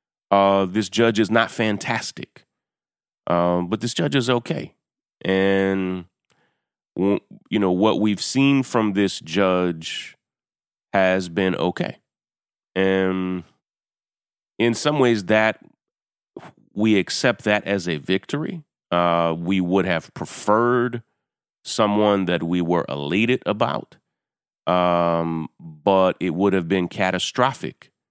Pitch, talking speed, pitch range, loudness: 95 Hz, 115 wpm, 90-110 Hz, -21 LUFS